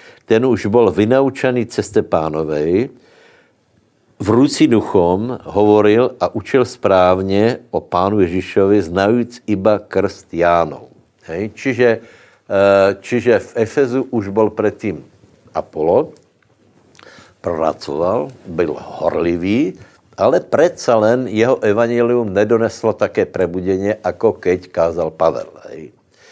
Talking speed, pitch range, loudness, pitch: 100 wpm, 95-115 Hz, -16 LUFS, 105 Hz